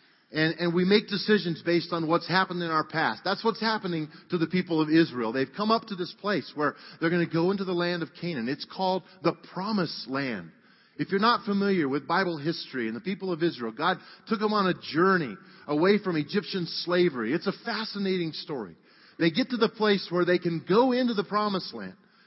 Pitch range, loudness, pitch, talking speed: 165-200 Hz, -27 LUFS, 180 Hz, 215 wpm